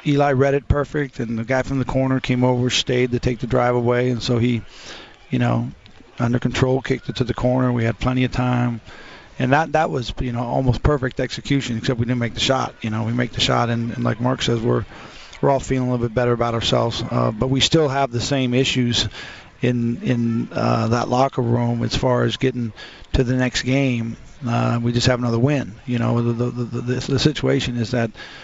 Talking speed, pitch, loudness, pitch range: 230 wpm, 125 Hz, -20 LUFS, 120-130 Hz